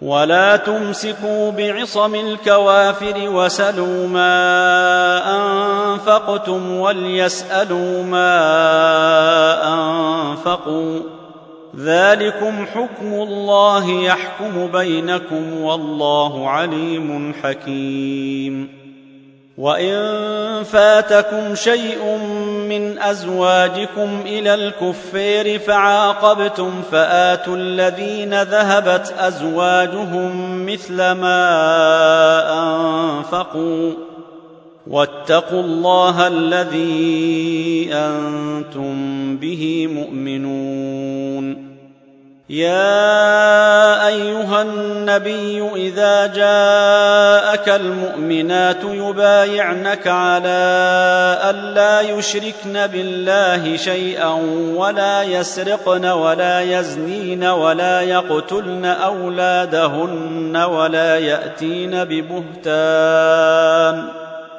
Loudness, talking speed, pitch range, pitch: -15 LUFS, 55 wpm, 160-205 Hz, 180 Hz